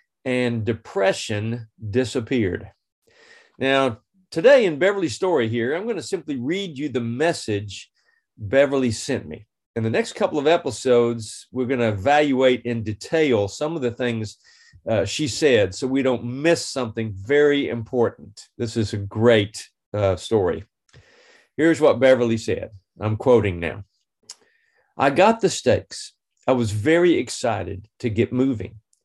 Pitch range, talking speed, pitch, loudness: 110-140 Hz, 145 wpm, 120 Hz, -21 LUFS